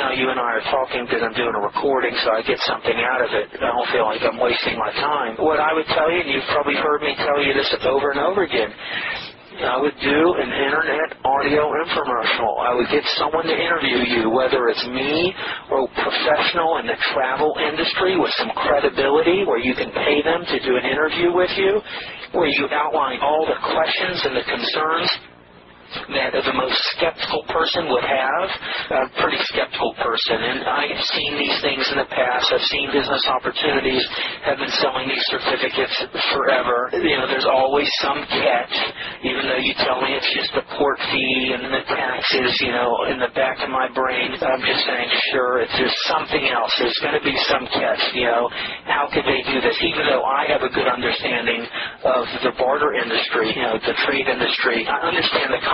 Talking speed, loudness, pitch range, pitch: 200 wpm, -19 LUFS, 130-155 Hz, 140 Hz